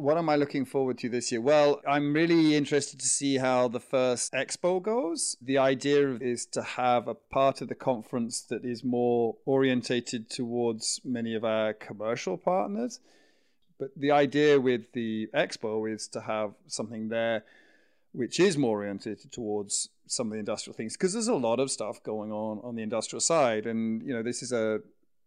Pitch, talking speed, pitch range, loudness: 125 Hz, 185 wpm, 115-145 Hz, -28 LUFS